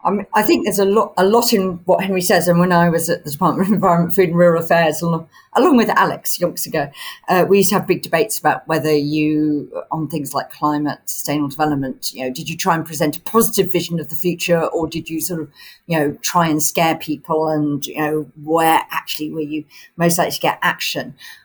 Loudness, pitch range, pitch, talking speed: -17 LUFS, 155-180 Hz, 165 Hz, 225 wpm